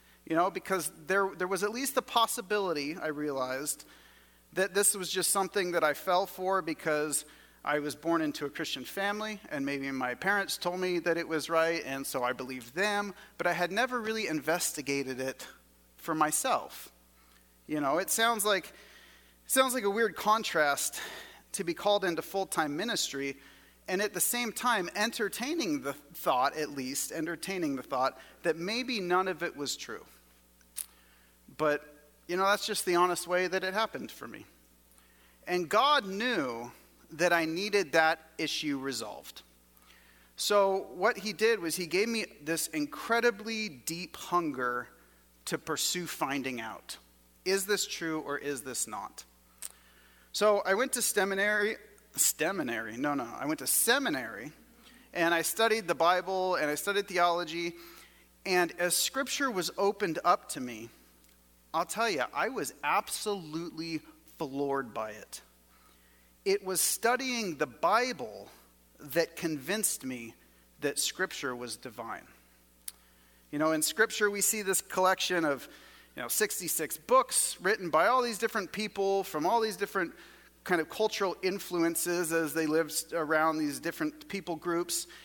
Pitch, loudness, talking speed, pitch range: 170 Hz, -31 LUFS, 155 wpm, 135-200 Hz